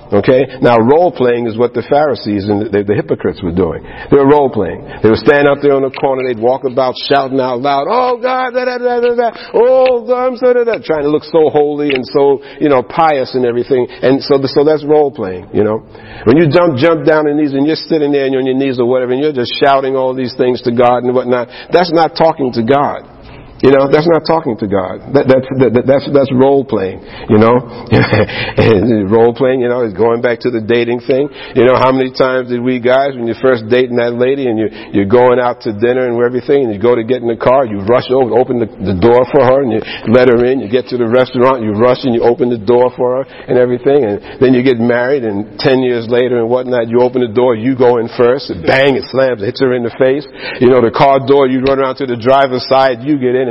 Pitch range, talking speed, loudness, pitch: 120-140 Hz, 260 wpm, -11 LUFS, 130 Hz